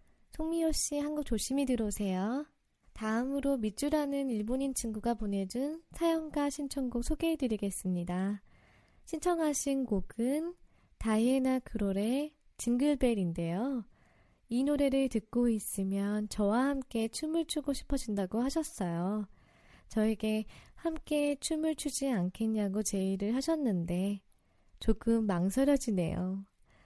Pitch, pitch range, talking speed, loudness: 240 Hz, 205-285 Hz, 265 characters per minute, -33 LUFS